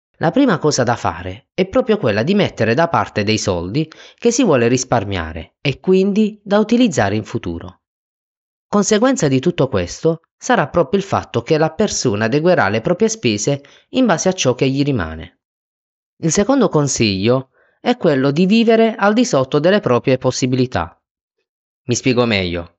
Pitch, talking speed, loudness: 140 Hz, 165 wpm, -16 LUFS